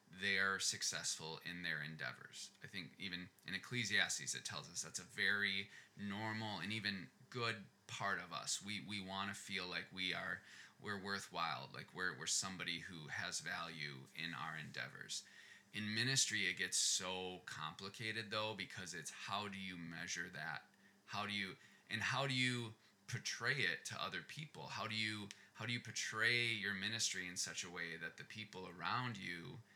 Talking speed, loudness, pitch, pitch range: 175 wpm, -42 LUFS, 100 Hz, 90-110 Hz